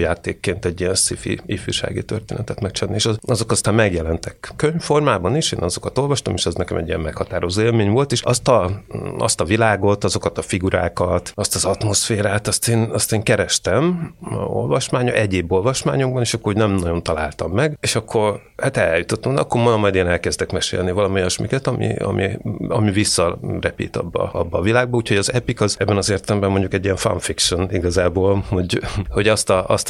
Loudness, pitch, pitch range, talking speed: -19 LUFS, 105 Hz, 95-120 Hz, 180 wpm